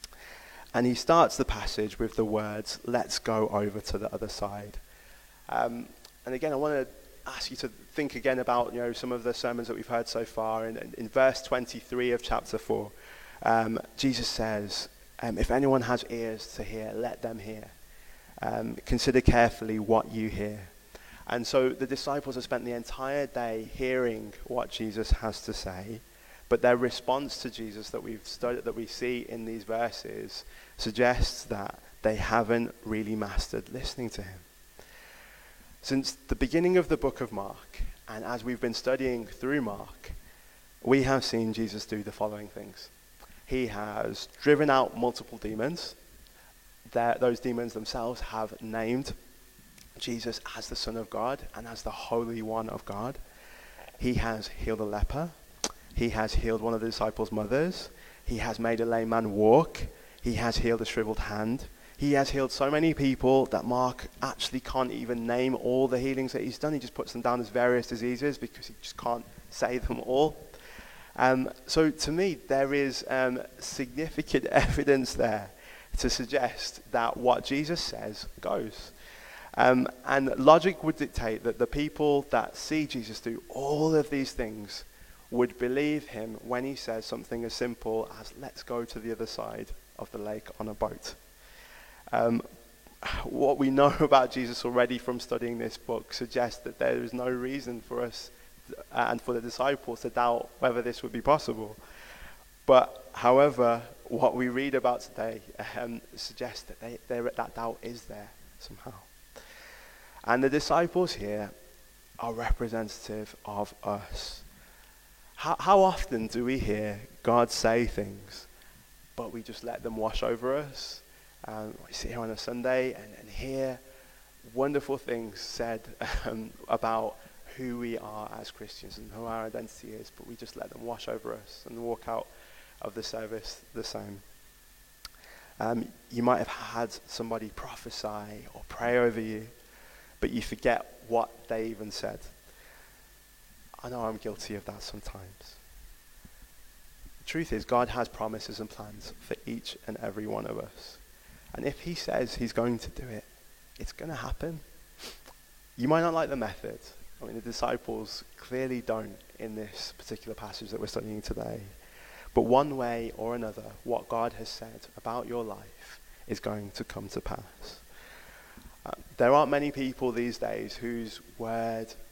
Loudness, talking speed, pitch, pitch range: -30 LUFS, 165 wpm, 115 Hz, 110-130 Hz